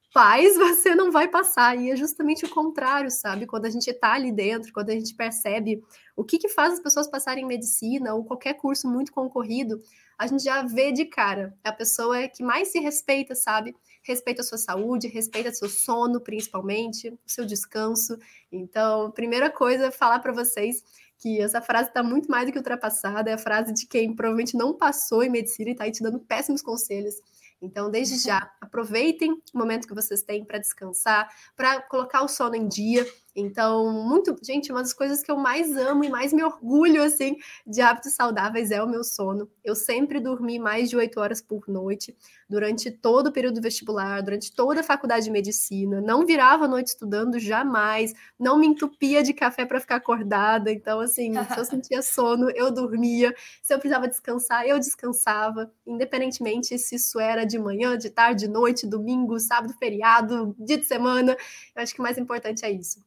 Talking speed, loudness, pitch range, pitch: 195 wpm, -24 LUFS, 220-260 Hz, 240 Hz